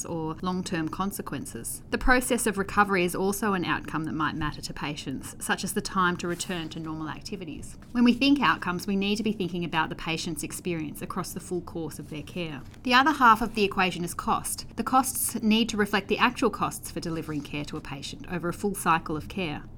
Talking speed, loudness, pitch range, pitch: 220 wpm, -27 LUFS, 160-210 Hz, 180 Hz